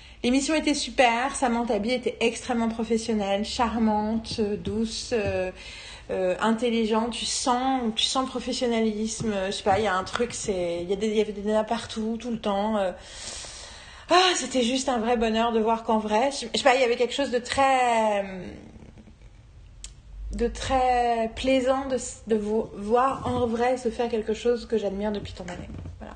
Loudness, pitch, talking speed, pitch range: -25 LUFS, 230 Hz, 180 wpm, 215-250 Hz